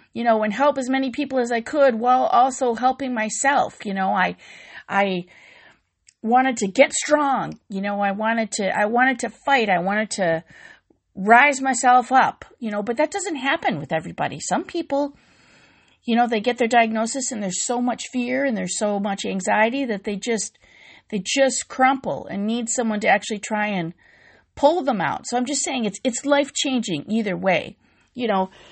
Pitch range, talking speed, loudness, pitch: 210-270 Hz, 190 wpm, -21 LUFS, 240 Hz